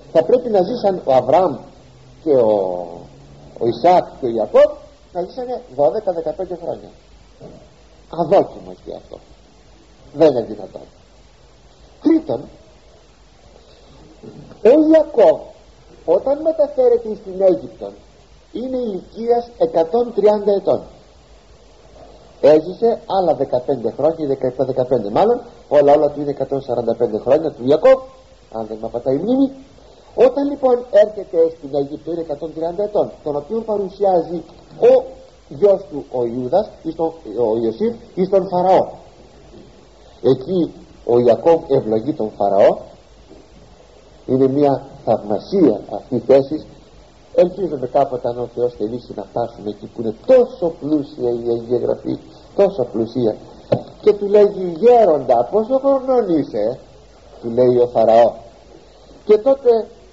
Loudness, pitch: -17 LUFS, 165 Hz